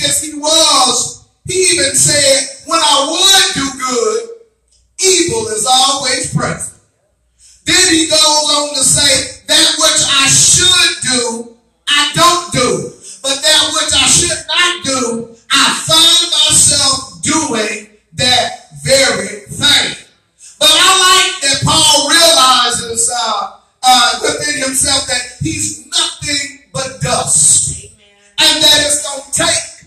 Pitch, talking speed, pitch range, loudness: 290 Hz, 125 wpm, 255-330 Hz, -9 LUFS